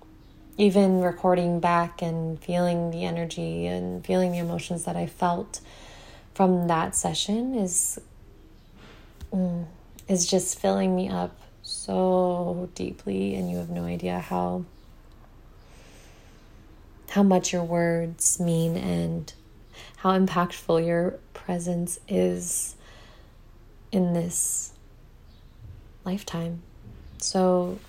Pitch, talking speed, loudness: 170 Hz, 100 wpm, -26 LUFS